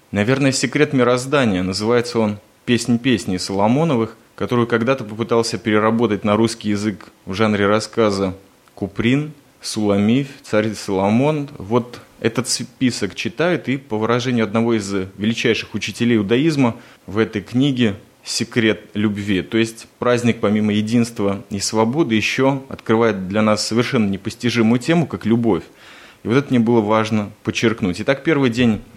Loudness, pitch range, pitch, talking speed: -18 LUFS, 105-125 Hz, 115 Hz, 135 wpm